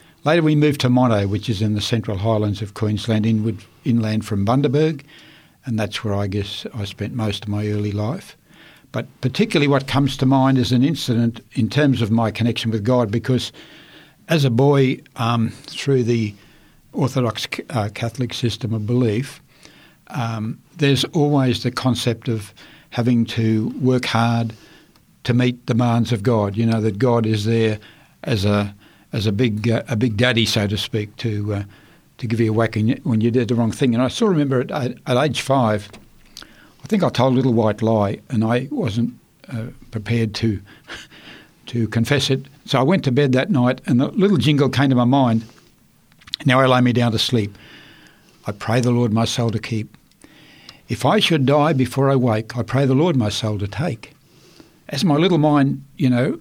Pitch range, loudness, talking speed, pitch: 110-135 Hz, -19 LUFS, 190 wpm, 120 Hz